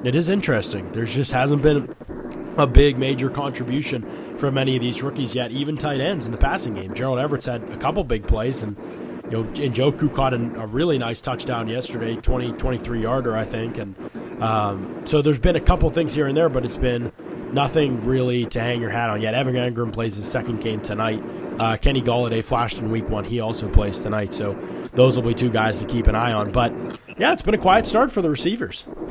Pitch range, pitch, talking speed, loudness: 115-135 Hz, 120 Hz, 220 wpm, -22 LUFS